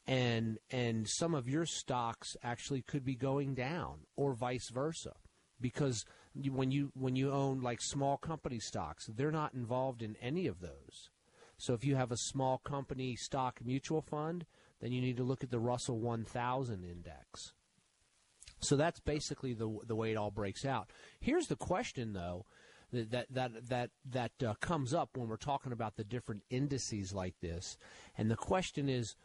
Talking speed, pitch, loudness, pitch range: 175 wpm, 125 Hz, -38 LUFS, 115-140 Hz